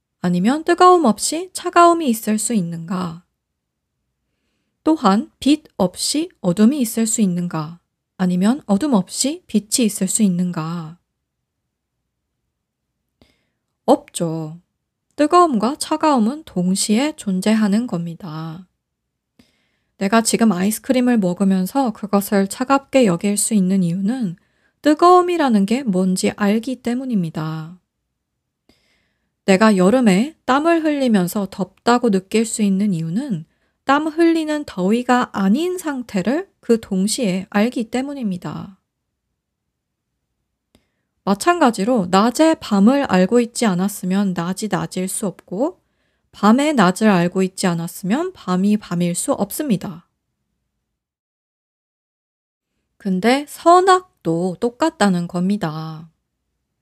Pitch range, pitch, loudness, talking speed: 185-260 Hz, 210 Hz, -18 LUFS, 225 characters per minute